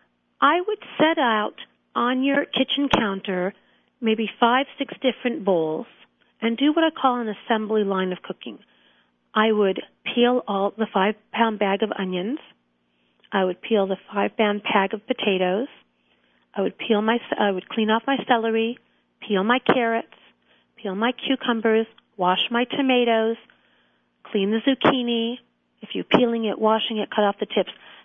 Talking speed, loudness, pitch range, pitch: 160 wpm, -23 LUFS, 195-245 Hz, 220 Hz